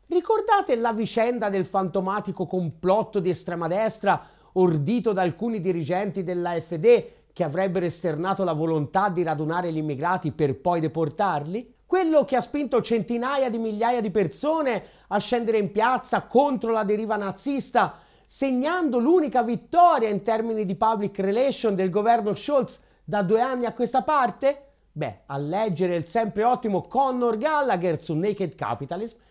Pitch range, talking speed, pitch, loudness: 185-245 Hz, 145 wpm, 215 Hz, -24 LUFS